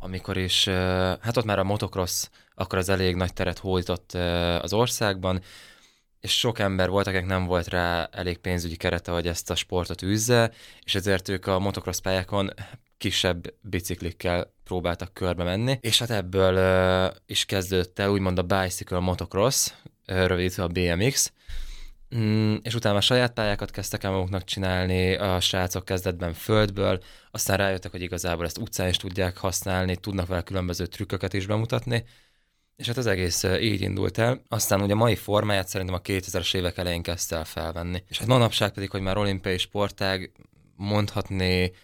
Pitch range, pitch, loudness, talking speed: 90-105 Hz, 95 Hz, -25 LUFS, 160 wpm